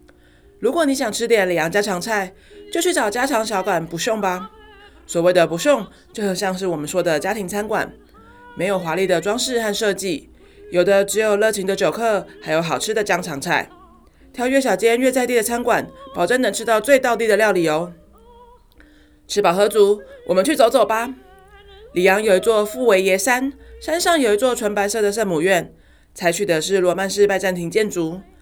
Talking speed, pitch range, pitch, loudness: 275 characters per minute, 185-245 Hz, 205 Hz, -19 LUFS